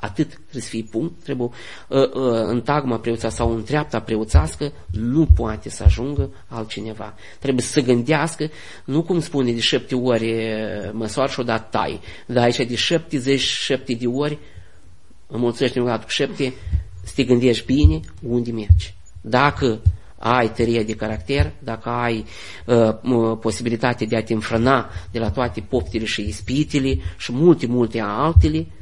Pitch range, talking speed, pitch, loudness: 105-130 Hz, 150 wpm, 115 Hz, -21 LUFS